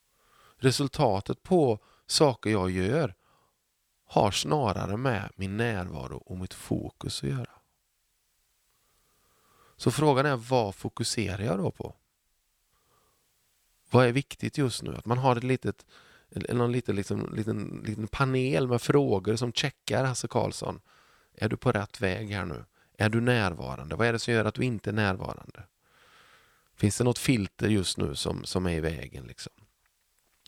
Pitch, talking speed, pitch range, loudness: 115 Hz, 155 wpm, 100-130 Hz, -28 LUFS